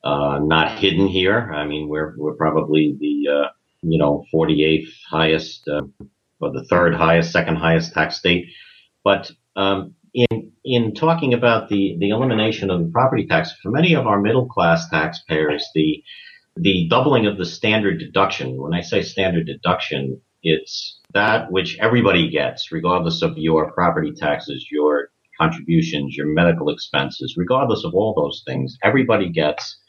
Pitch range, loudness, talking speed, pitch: 75-100 Hz, -19 LUFS, 155 wpm, 85 Hz